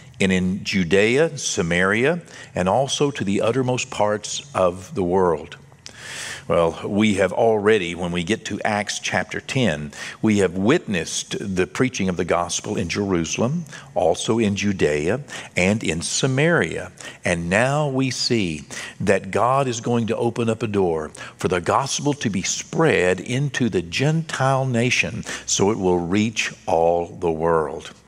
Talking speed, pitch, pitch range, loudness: 150 wpm, 105 Hz, 90-125 Hz, -21 LUFS